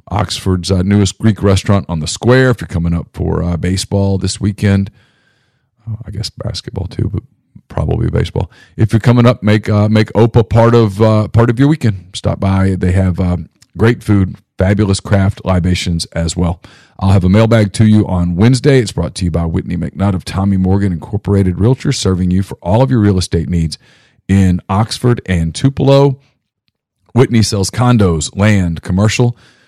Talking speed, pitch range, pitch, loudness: 185 wpm, 95-115 Hz, 100 Hz, -13 LUFS